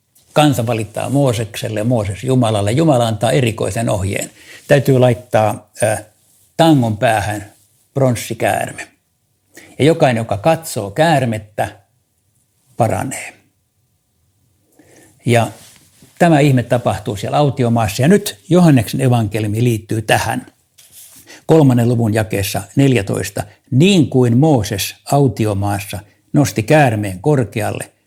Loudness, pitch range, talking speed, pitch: -15 LUFS, 105-135 Hz, 95 wpm, 120 Hz